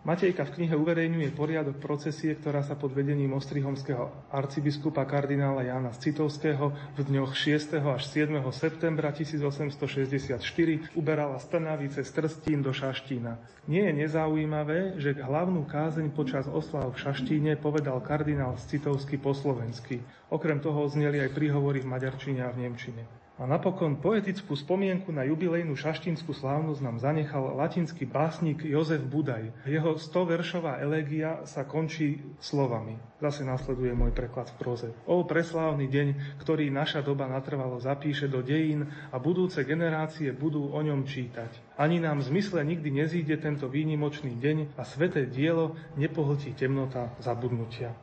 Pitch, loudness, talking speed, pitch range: 145 Hz, -30 LUFS, 140 wpm, 135-155 Hz